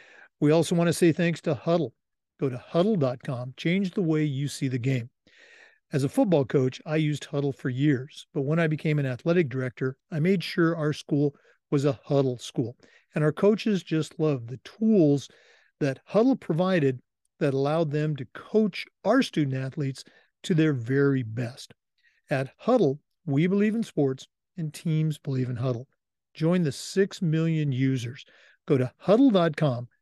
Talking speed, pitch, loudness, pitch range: 170 wpm, 155 Hz, -26 LUFS, 135-175 Hz